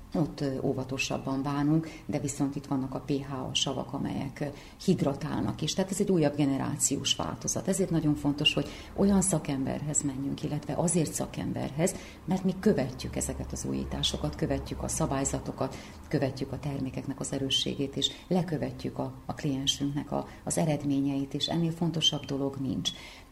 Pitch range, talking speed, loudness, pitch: 135-155 Hz, 145 wpm, -30 LUFS, 145 Hz